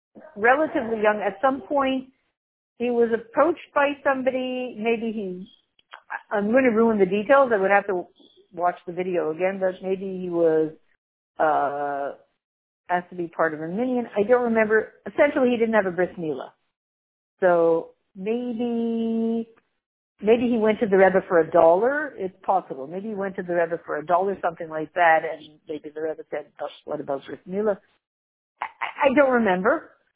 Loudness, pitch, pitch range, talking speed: -23 LUFS, 200 Hz, 170-240 Hz, 170 wpm